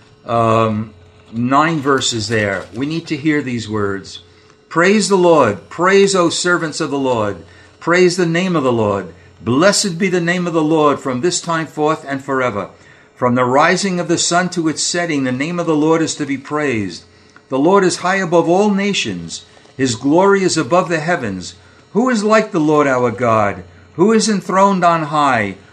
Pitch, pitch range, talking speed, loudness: 150 Hz, 115-175 Hz, 190 wpm, -15 LUFS